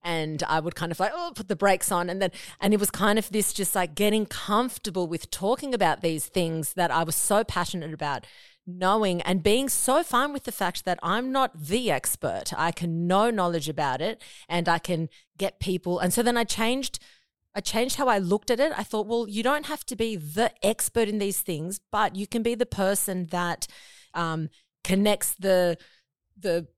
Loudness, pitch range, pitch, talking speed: -26 LUFS, 175-225 Hz, 195 Hz, 210 wpm